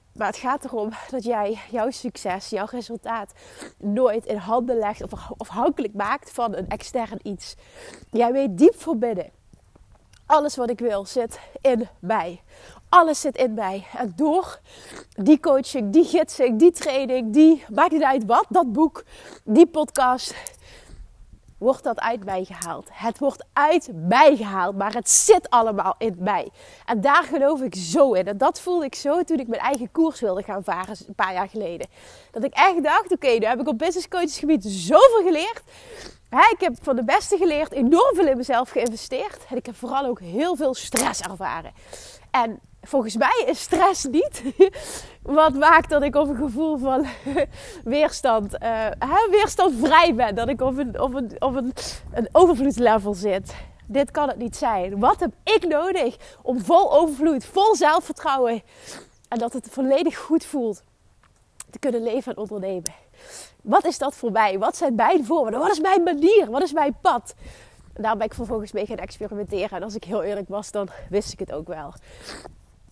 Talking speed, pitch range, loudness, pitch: 180 wpm, 225-320 Hz, -21 LUFS, 265 Hz